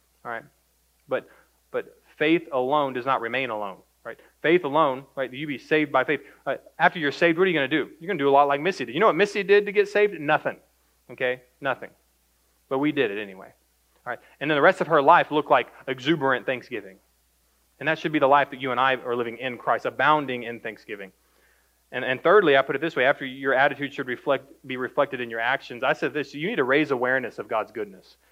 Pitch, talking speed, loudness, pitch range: 135 Hz, 240 wpm, -23 LUFS, 125-155 Hz